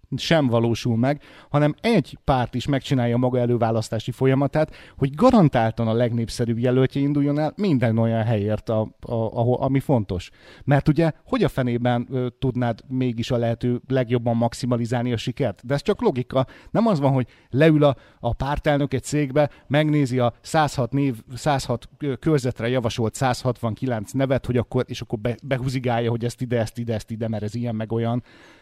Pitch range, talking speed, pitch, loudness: 115-140 Hz, 160 wpm, 125 Hz, -22 LUFS